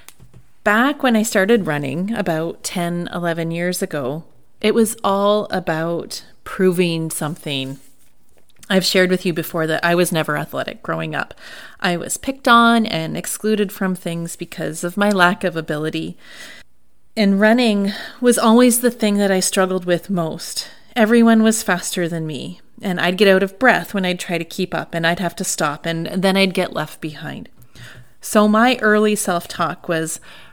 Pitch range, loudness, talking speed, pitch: 165-210 Hz, -18 LUFS, 170 wpm, 180 Hz